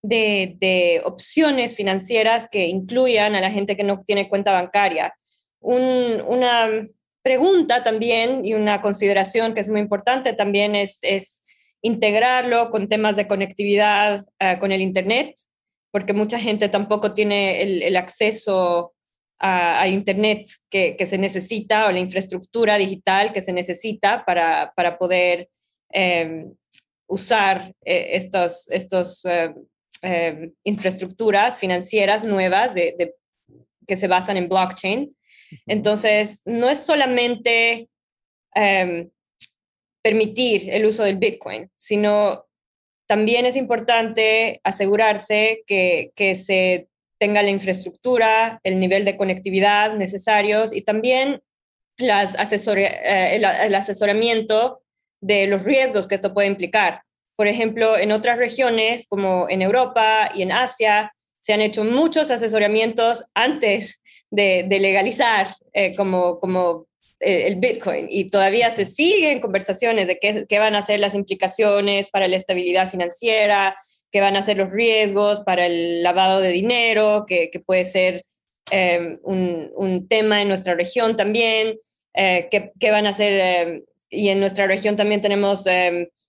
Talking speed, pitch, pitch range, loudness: 140 wpm, 205 Hz, 190-220 Hz, -19 LUFS